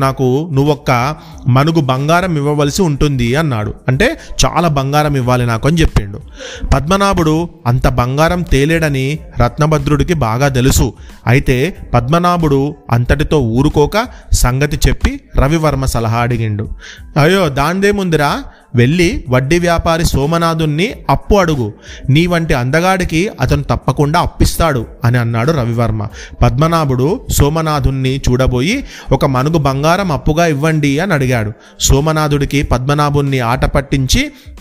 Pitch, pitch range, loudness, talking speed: 145 Hz, 130-165 Hz, -13 LUFS, 105 wpm